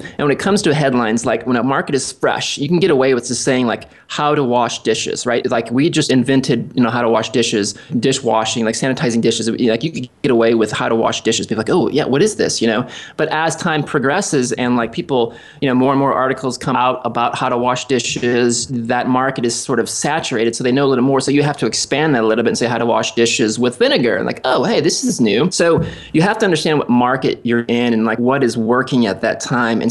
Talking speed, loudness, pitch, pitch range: 265 wpm, -16 LUFS, 125 Hz, 120-140 Hz